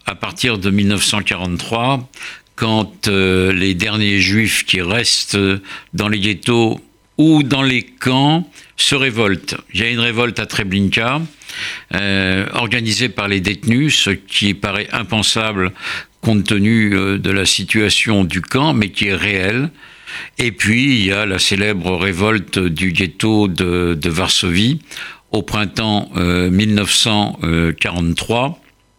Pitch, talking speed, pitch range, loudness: 105 Hz, 135 wpm, 95-115 Hz, -15 LUFS